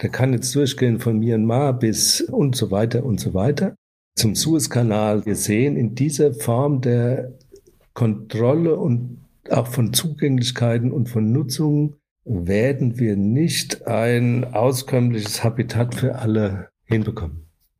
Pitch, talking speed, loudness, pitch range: 120 Hz, 130 wpm, -20 LUFS, 110-140 Hz